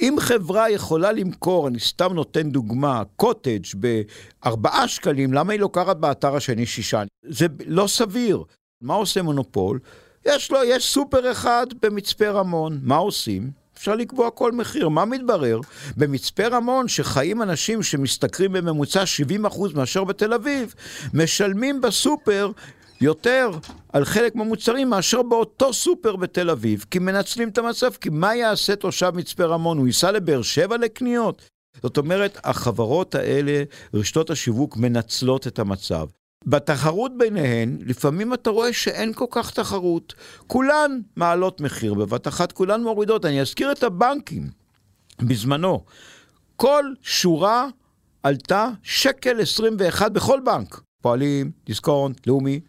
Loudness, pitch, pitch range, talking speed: -21 LUFS, 180 Hz, 140-225 Hz, 130 wpm